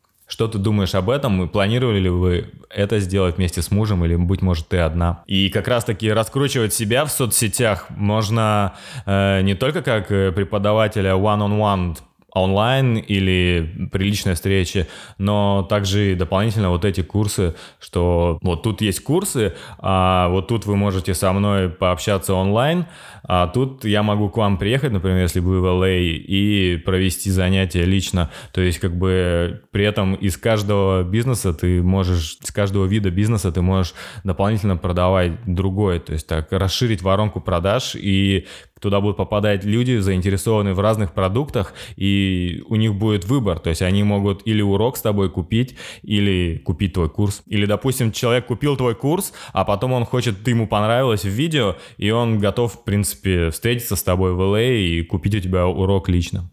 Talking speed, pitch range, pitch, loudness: 170 wpm, 95-110 Hz, 100 Hz, -19 LUFS